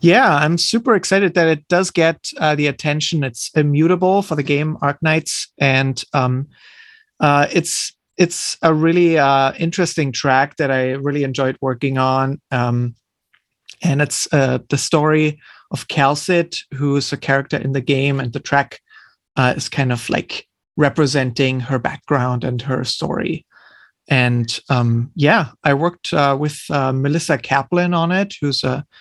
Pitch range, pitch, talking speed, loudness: 135-165 Hz, 145 Hz, 155 wpm, -17 LUFS